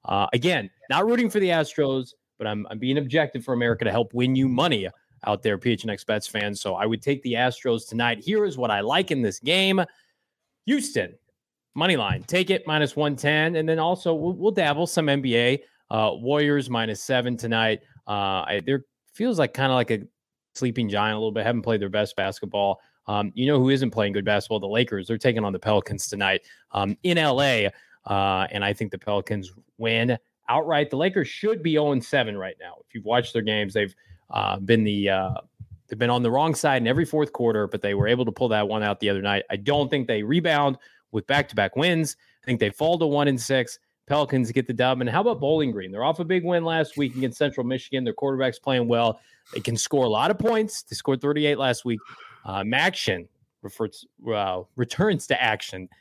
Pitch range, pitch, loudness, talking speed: 110-145 Hz, 125 Hz, -24 LUFS, 215 wpm